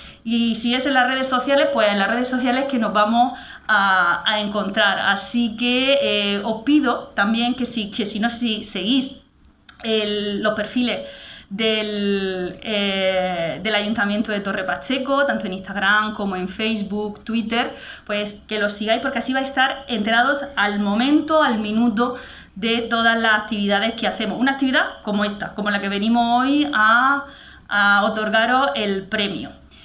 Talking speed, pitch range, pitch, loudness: 165 wpm, 205-250 Hz, 220 Hz, -20 LUFS